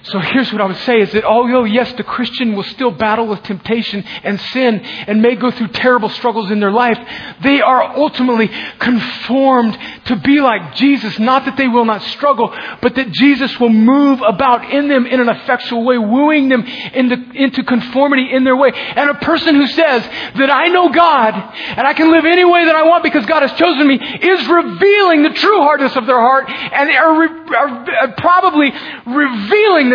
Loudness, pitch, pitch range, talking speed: -12 LUFS, 255 Hz, 230-285 Hz, 200 wpm